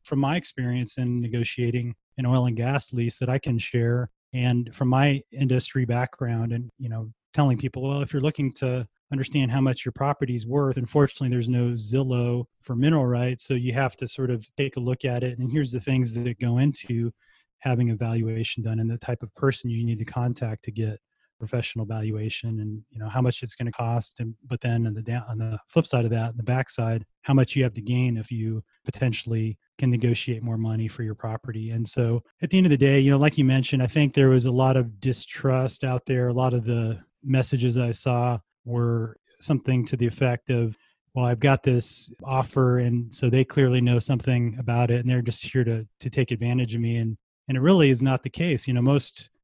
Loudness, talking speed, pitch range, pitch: -25 LUFS, 225 wpm, 115-130 Hz, 125 Hz